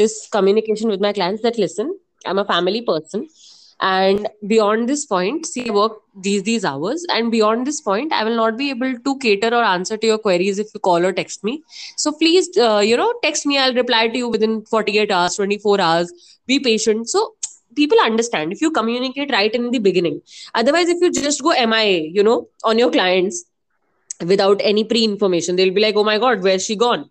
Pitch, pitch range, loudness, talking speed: 220 Hz, 200-245 Hz, -17 LUFS, 210 wpm